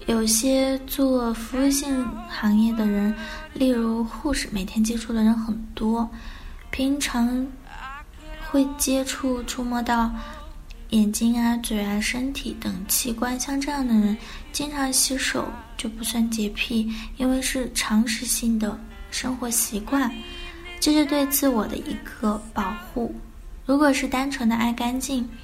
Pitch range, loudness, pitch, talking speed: 225-265 Hz, -24 LUFS, 240 Hz, 200 characters per minute